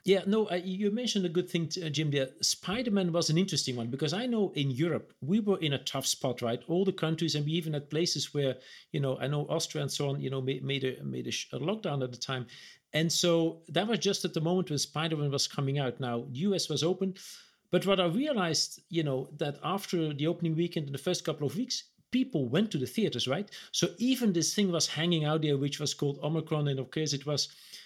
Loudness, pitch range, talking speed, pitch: -31 LUFS, 140-180 Hz, 240 wpm, 160 Hz